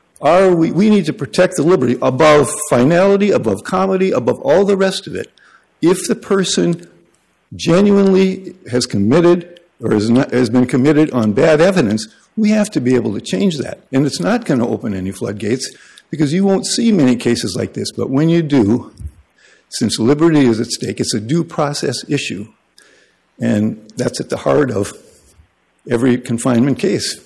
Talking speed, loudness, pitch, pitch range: 175 wpm, -15 LUFS, 150 Hz, 125-185 Hz